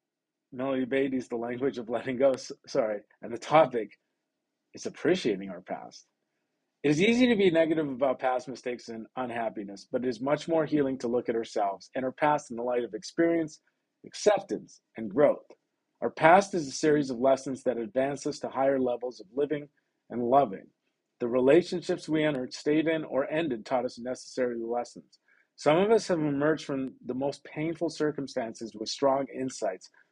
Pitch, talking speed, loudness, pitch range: 135 Hz, 175 wpm, -28 LUFS, 125-150 Hz